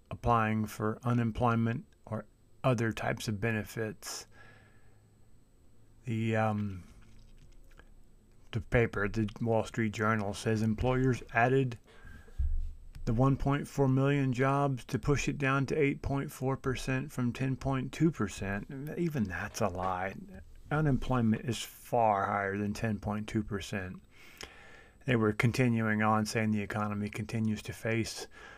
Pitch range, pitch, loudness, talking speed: 105-130 Hz, 115 Hz, -32 LUFS, 105 wpm